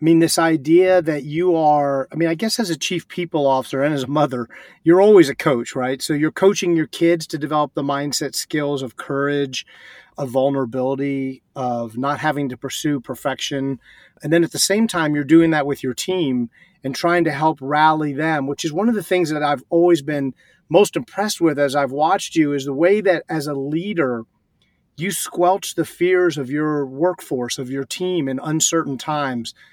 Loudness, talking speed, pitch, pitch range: -19 LUFS, 200 wpm, 155 Hz, 140-170 Hz